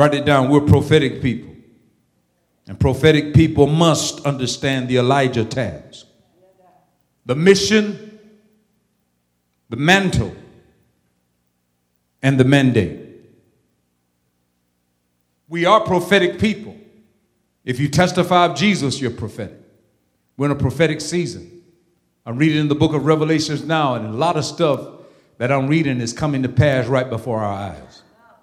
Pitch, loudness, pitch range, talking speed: 140 Hz, -17 LUFS, 100-165 Hz, 130 wpm